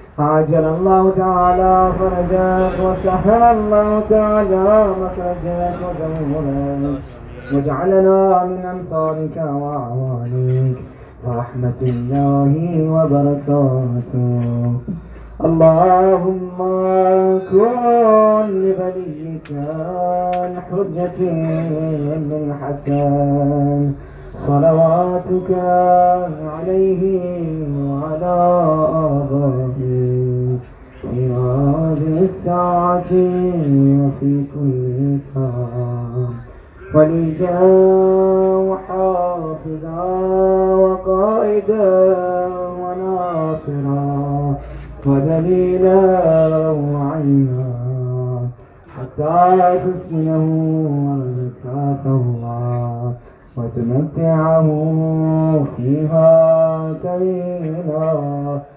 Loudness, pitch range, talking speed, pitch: -16 LUFS, 140-180 Hz, 40 wpm, 160 Hz